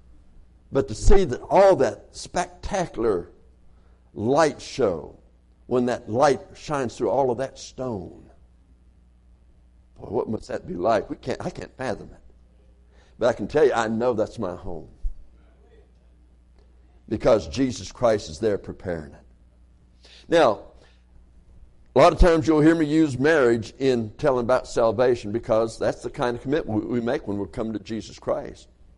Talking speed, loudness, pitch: 155 wpm, -23 LUFS, 85 Hz